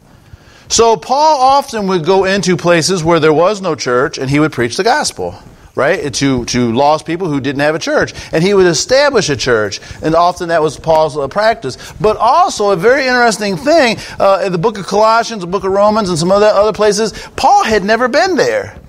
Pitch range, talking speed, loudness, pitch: 160-225 Hz, 215 wpm, -12 LUFS, 195 Hz